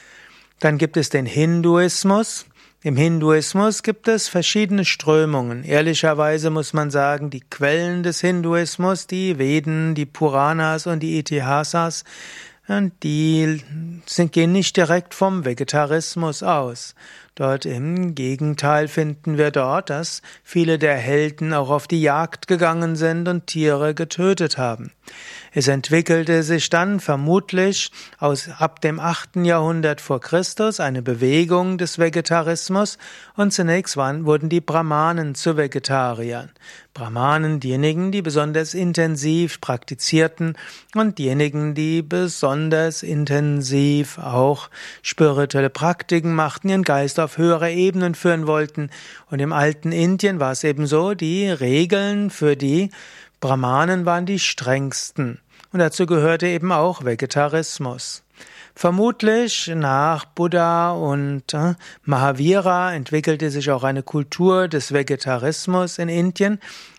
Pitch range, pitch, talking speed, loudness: 145-175 Hz, 160 Hz, 120 wpm, -19 LUFS